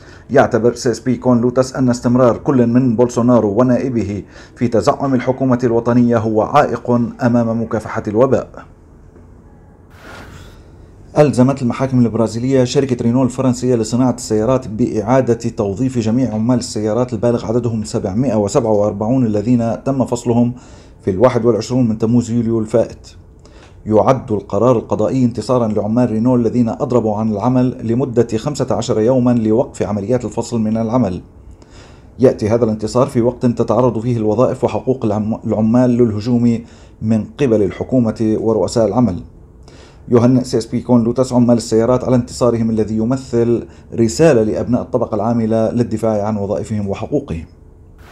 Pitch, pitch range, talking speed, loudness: 115 Hz, 110-125 Hz, 125 wpm, -15 LUFS